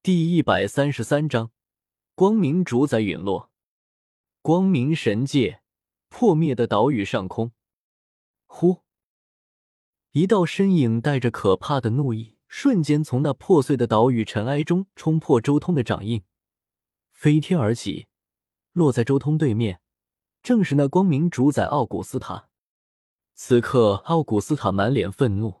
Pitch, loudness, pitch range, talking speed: 135 Hz, -22 LUFS, 110-160 Hz, 200 characters per minute